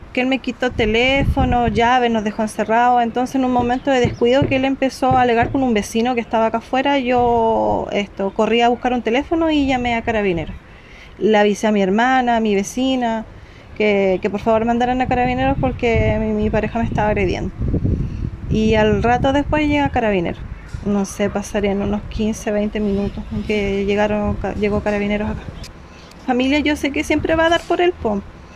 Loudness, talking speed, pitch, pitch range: -18 LUFS, 185 wpm, 230 Hz, 210-255 Hz